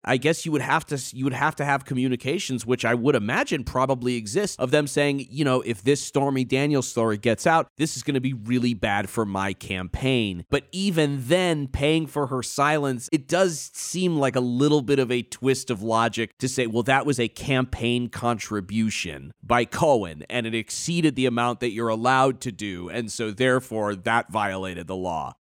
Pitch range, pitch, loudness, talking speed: 115-145 Hz, 130 Hz, -24 LUFS, 205 wpm